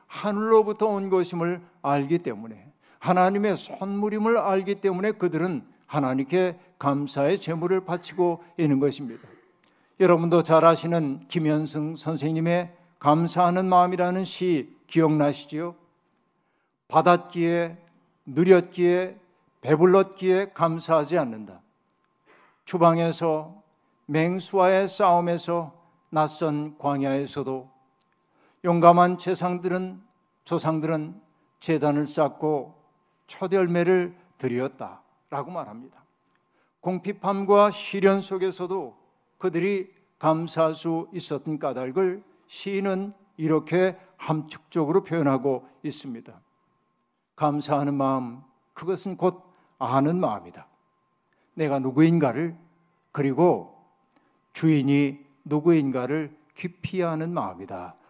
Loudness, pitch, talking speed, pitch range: -24 LUFS, 170 Hz, 240 characters per minute, 150-180 Hz